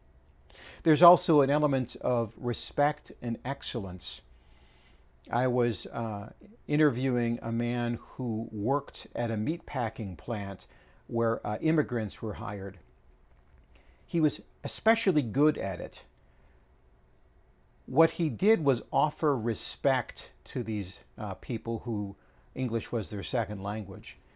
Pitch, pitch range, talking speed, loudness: 115 Hz, 75-130 Hz, 115 wpm, -30 LUFS